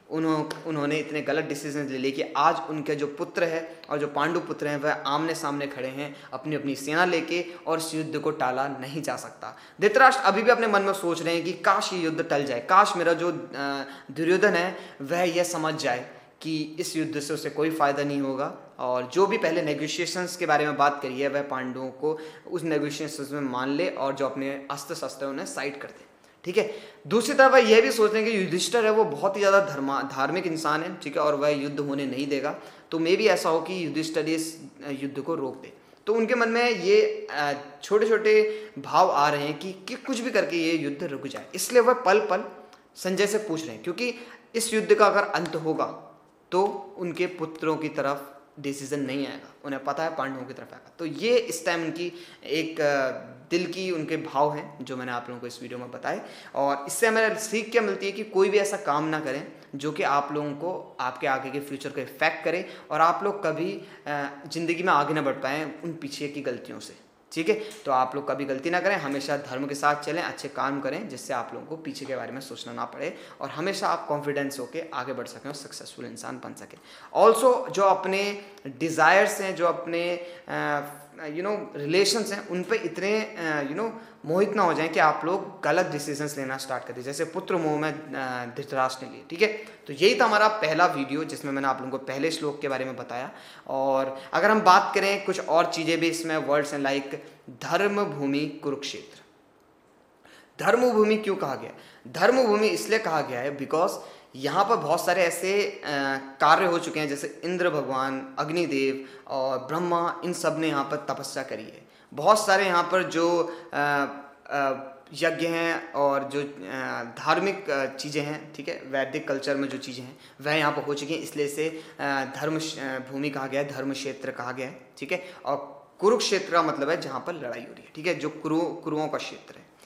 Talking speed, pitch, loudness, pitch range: 210 wpm, 155 Hz, -26 LUFS, 140-180 Hz